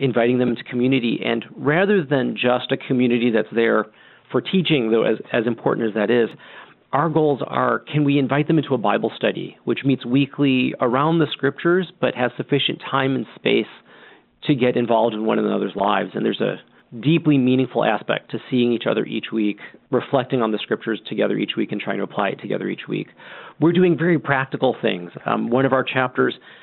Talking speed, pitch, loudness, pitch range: 200 wpm, 130 Hz, -20 LUFS, 120-145 Hz